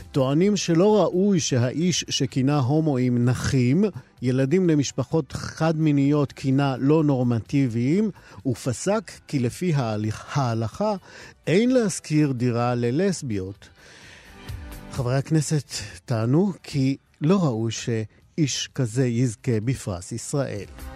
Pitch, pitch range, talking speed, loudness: 135 Hz, 115-155 Hz, 95 wpm, -23 LUFS